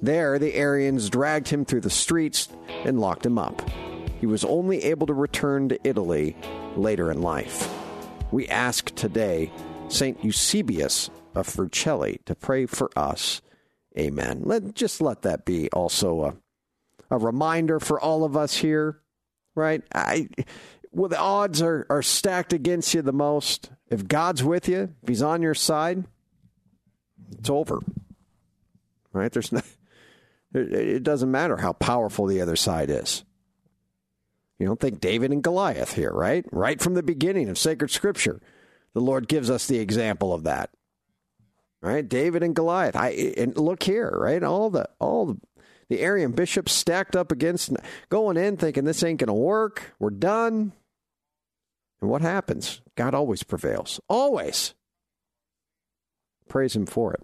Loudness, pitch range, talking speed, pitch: -25 LUFS, 125-175 Hz, 155 wpm, 150 Hz